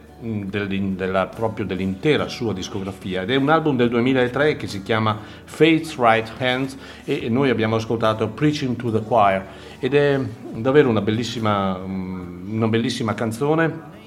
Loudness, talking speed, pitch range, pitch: -21 LUFS, 140 wpm, 100-130 Hz, 115 Hz